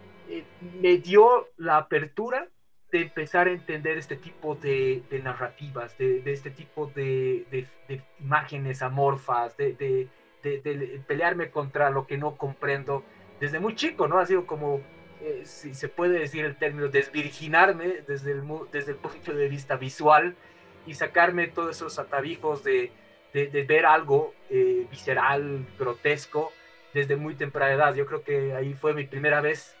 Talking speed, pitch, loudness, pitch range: 160 wpm, 150 Hz, -26 LUFS, 140-180 Hz